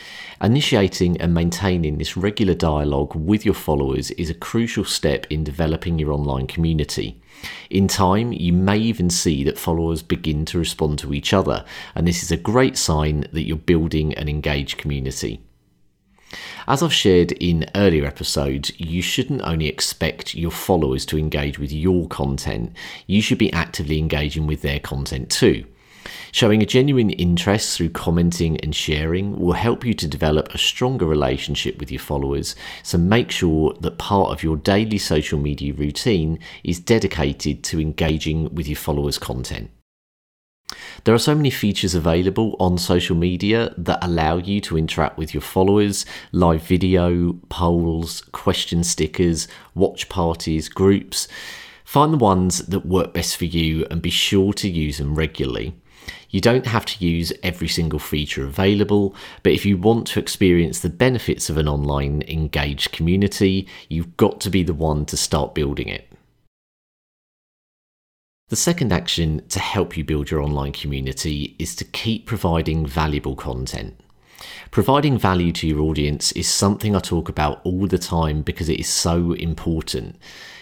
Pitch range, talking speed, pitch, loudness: 75-95 Hz, 160 wpm, 85 Hz, -20 LUFS